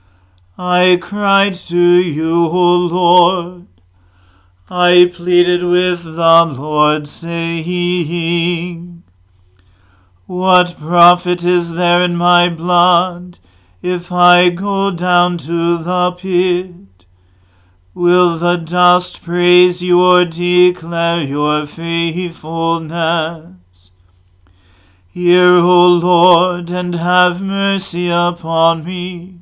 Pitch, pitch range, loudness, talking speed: 175 Hz, 160-180 Hz, -13 LUFS, 90 wpm